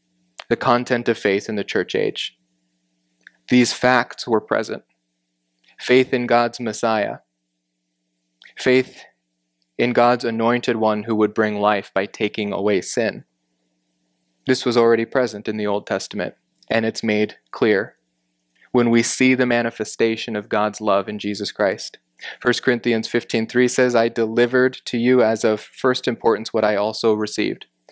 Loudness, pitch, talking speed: -20 LUFS, 110 Hz, 145 wpm